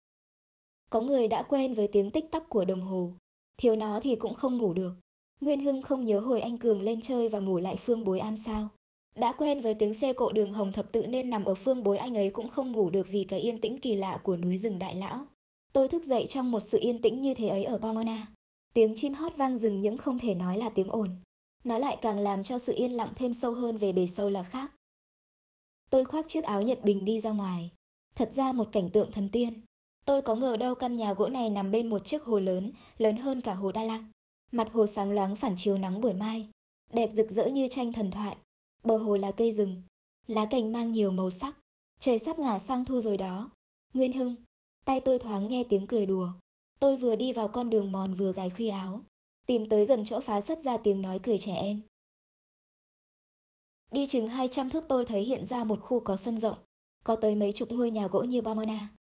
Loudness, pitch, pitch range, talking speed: -30 LUFS, 225 Hz, 205-250 Hz, 235 wpm